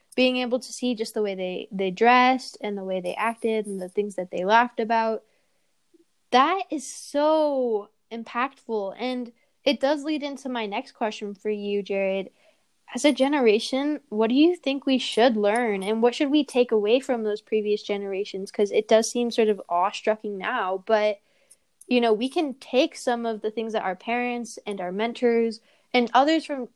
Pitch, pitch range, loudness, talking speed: 230 Hz, 210-260 Hz, -24 LUFS, 190 wpm